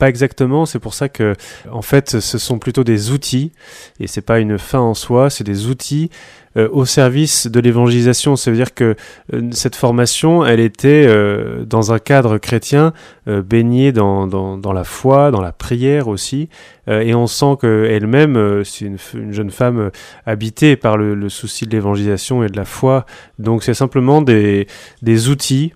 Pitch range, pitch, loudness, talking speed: 105-135 Hz, 120 Hz, -14 LUFS, 190 wpm